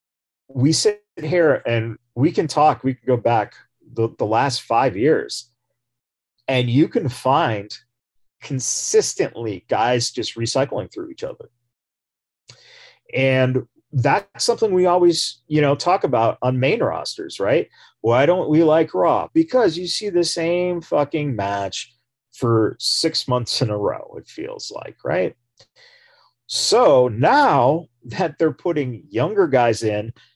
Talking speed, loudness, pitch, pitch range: 140 wpm, -19 LUFS, 130 Hz, 120-170 Hz